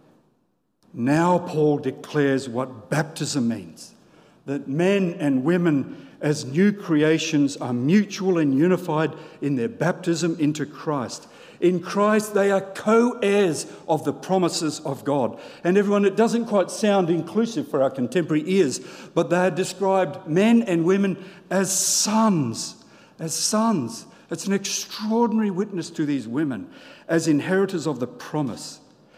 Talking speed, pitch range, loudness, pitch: 140 wpm, 150-200 Hz, -22 LUFS, 175 Hz